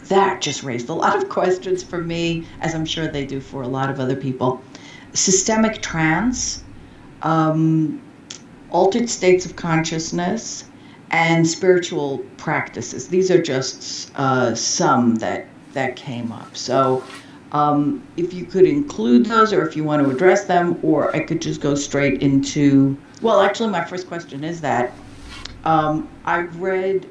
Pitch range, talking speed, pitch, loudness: 135-185 Hz, 155 wpm, 160 Hz, -19 LUFS